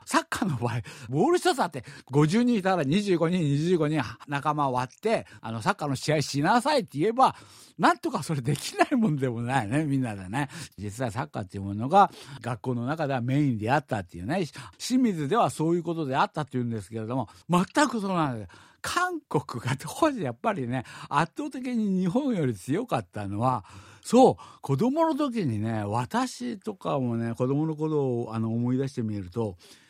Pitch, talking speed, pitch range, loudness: 145 Hz, 360 characters per minute, 120-205 Hz, -27 LUFS